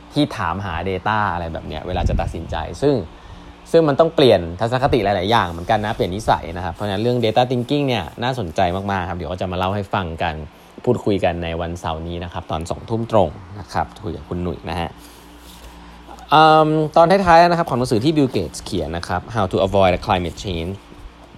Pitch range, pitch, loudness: 85-115 Hz, 95 Hz, -19 LUFS